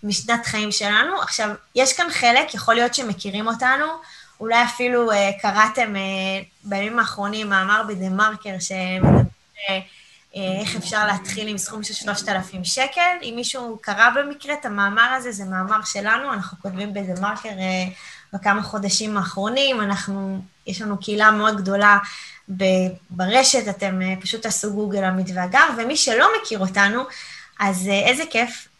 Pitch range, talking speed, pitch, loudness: 195-235 Hz, 145 wpm, 210 Hz, -20 LUFS